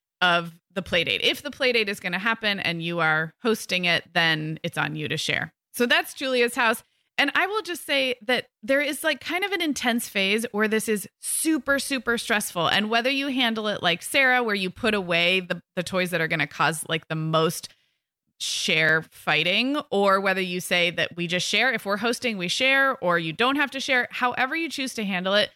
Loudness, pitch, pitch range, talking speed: -23 LUFS, 210 Hz, 175-255 Hz, 220 wpm